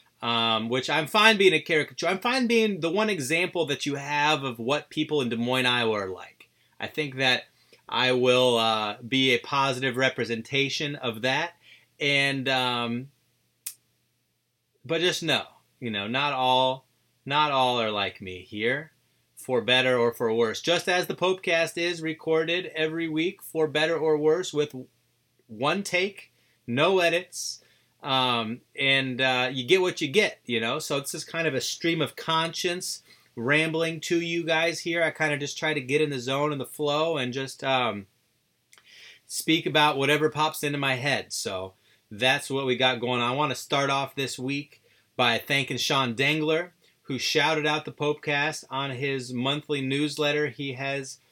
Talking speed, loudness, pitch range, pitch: 175 wpm, -25 LUFS, 125-160 Hz, 145 Hz